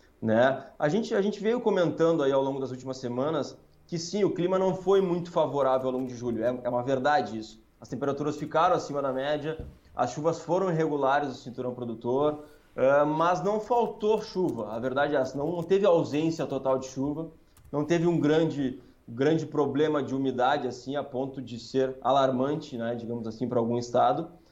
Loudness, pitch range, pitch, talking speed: -27 LUFS, 130-165 Hz, 145 Hz, 190 wpm